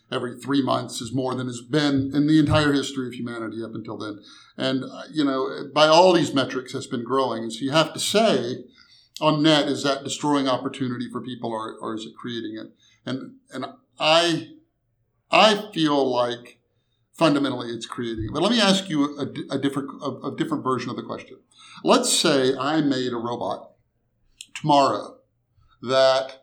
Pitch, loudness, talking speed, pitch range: 130 Hz, -22 LUFS, 180 wpm, 120-145 Hz